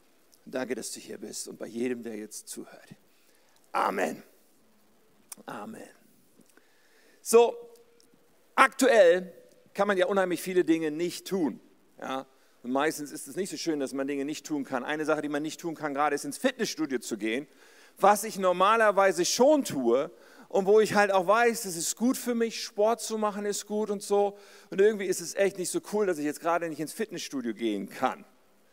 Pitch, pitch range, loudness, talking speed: 190 Hz, 155-220 Hz, -27 LUFS, 190 wpm